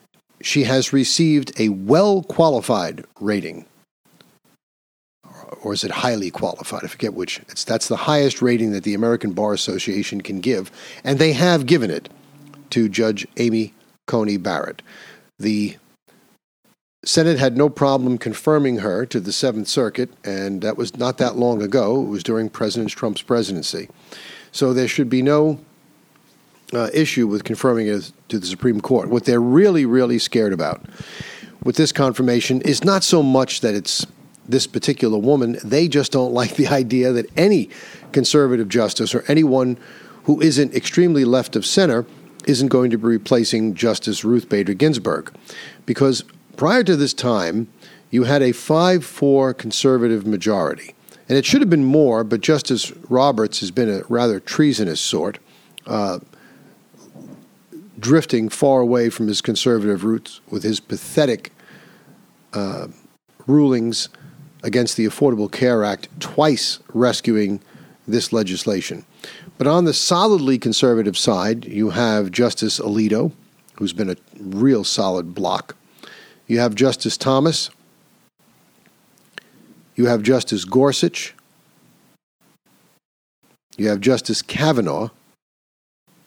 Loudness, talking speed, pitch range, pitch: -18 LUFS, 135 wpm, 110-140 Hz, 125 Hz